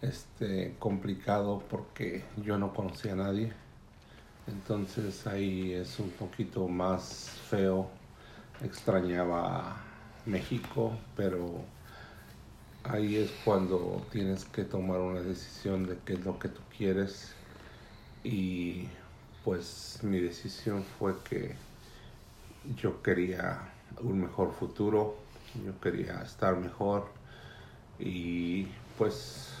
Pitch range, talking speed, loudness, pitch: 90-105 Hz, 105 wpm, -35 LUFS, 95 Hz